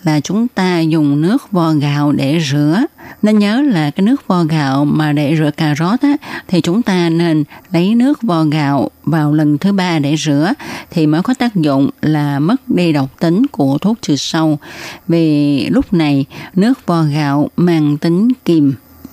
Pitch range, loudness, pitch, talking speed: 150-200 Hz, -14 LUFS, 160 Hz, 180 wpm